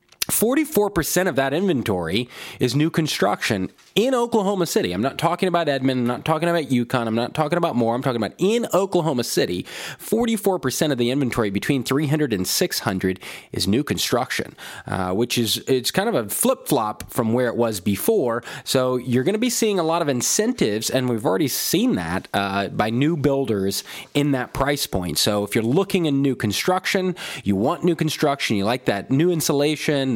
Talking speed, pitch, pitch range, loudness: 195 wpm, 140 Hz, 120-175 Hz, -21 LUFS